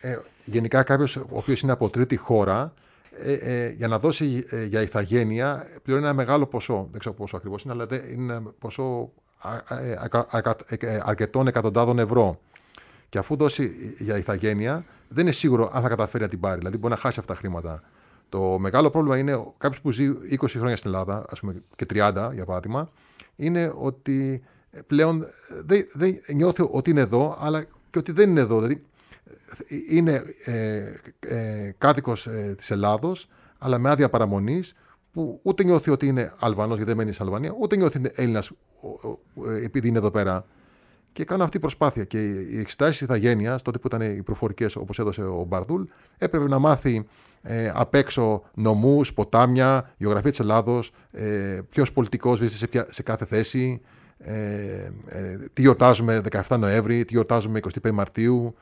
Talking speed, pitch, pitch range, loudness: 170 wpm, 120 Hz, 110-140 Hz, -24 LUFS